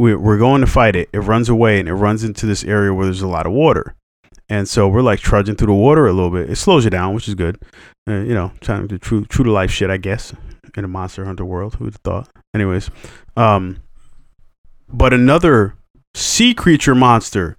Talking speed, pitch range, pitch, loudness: 220 wpm, 95-115 Hz, 105 Hz, -15 LUFS